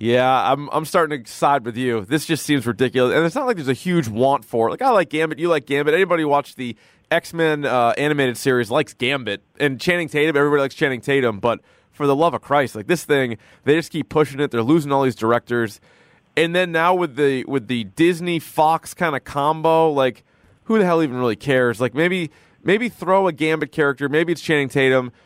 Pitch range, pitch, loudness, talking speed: 130-160 Hz, 145 Hz, -19 LUFS, 225 wpm